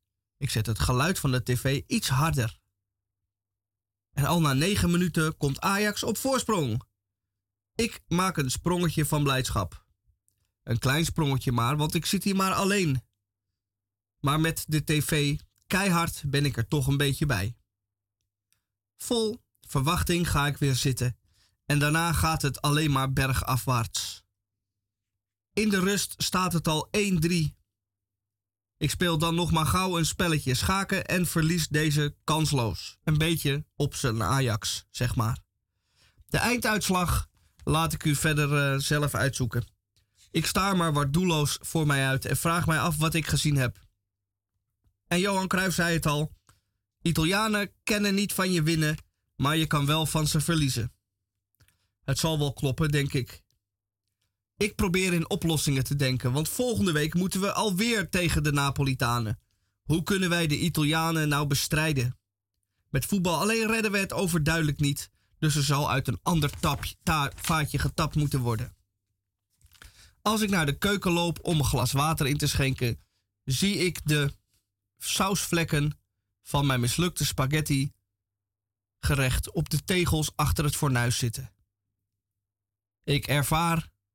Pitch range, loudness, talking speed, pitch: 105-165 Hz, -26 LUFS, 150 wpm, 140 Hz